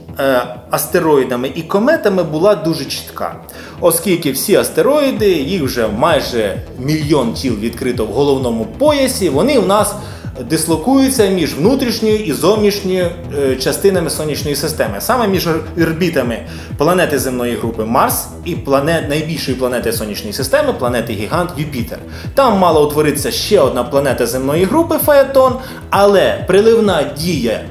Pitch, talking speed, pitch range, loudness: 160 Hz, 125 wpm, 130-200 Hz, -14 LUFS